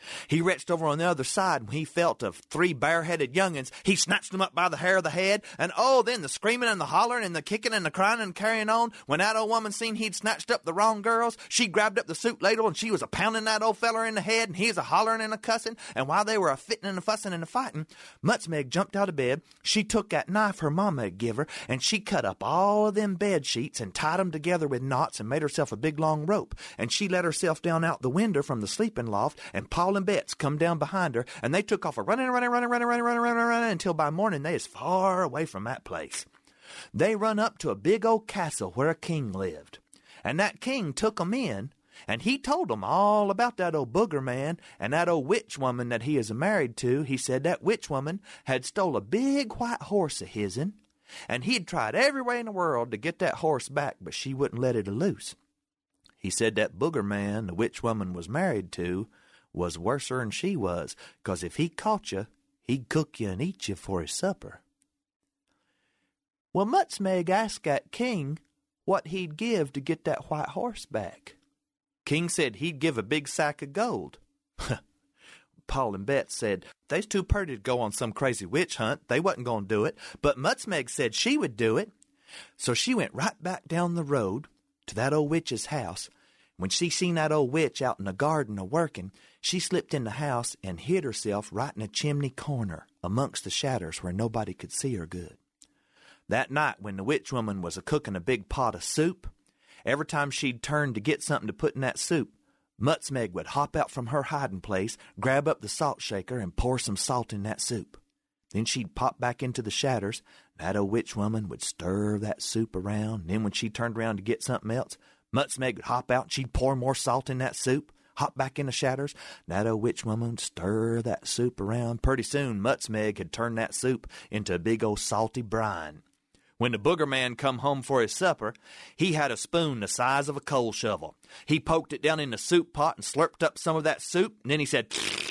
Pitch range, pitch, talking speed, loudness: 120-200 Hz, 150 Hz, 225 wpm, -28 LUFS